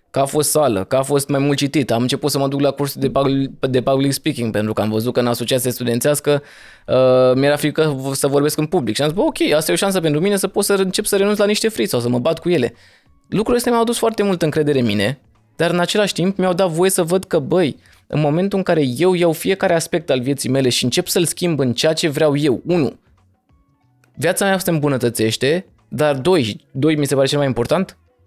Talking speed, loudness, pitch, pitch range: 245 wpm, -17 LUFS, 145 Hz, 130-180 Hz